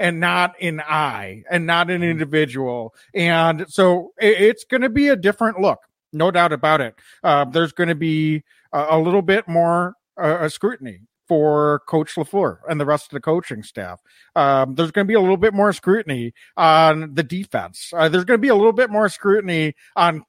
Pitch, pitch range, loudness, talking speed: 170 Hz, 155-195 Hz, -18 LUFS, 195 wpm